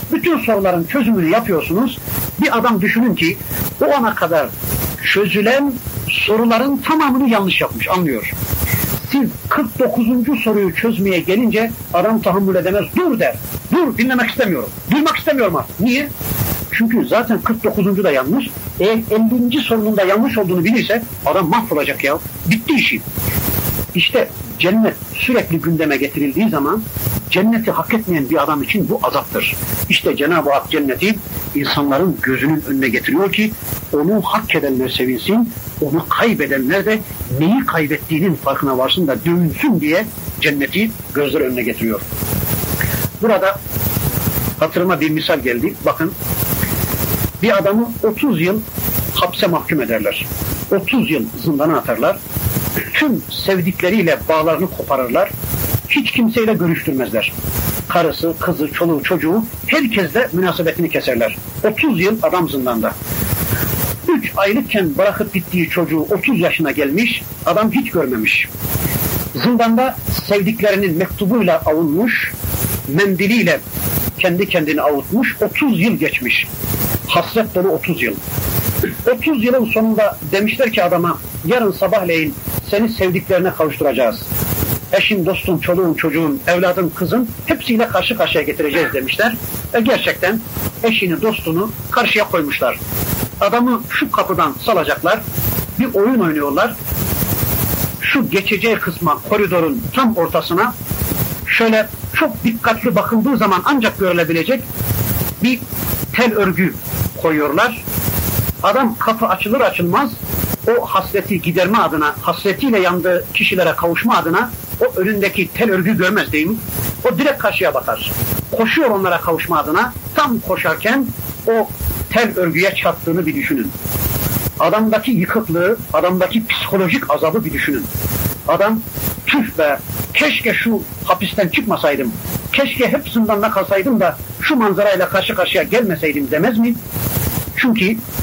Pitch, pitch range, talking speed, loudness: 195 Hz, 165-230 Hz, 115 wpm, -16 LUFS